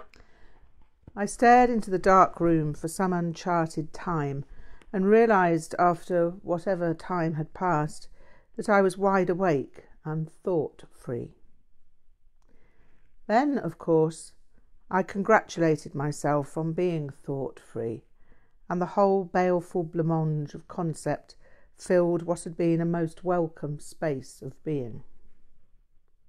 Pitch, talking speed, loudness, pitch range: 170 Hz, 120 wpm, -26 LUFS, 160-185 Hz